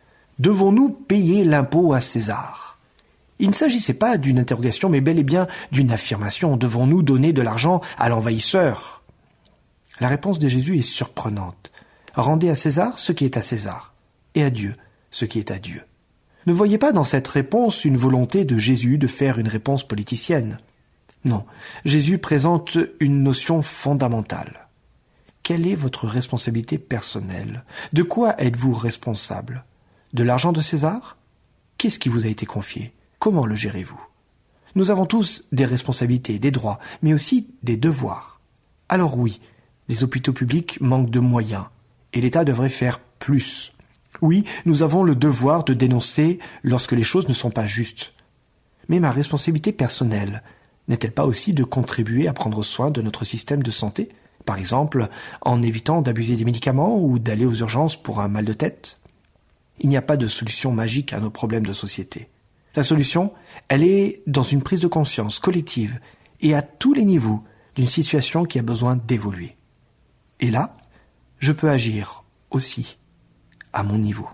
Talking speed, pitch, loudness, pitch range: 165 wpm, 130 Hz, -20 LUFS, 115-155 Hz